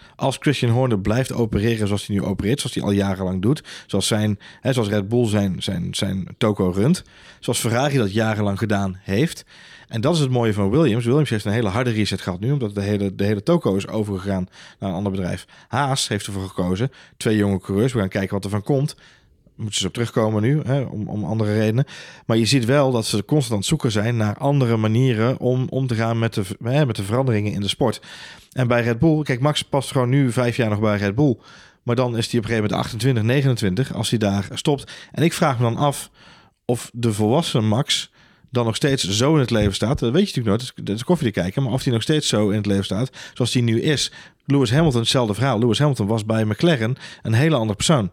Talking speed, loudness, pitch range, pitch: 240 wpm, -21 LUFS, 105-135 Hz, 115 Hz